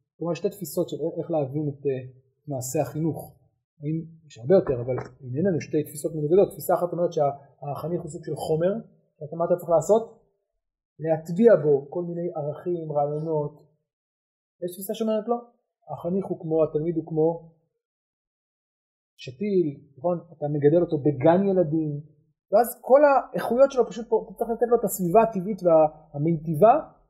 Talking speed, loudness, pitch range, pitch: 155 wpm, -24 LUFS, 150-190 Hz, 165 Hz